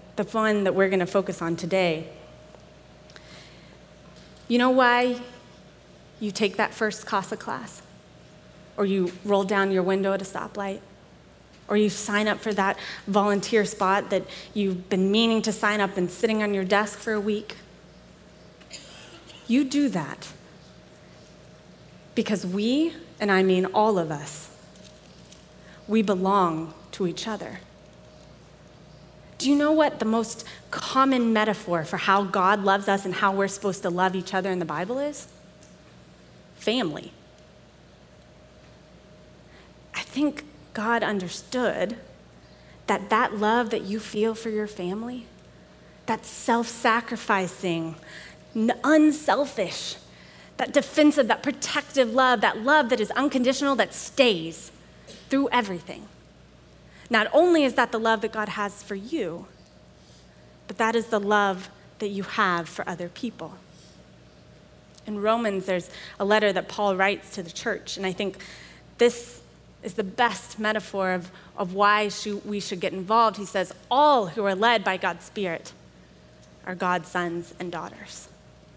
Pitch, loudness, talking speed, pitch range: 205 Hz, -24 LUFS, 140 wpm, 185-225 Hz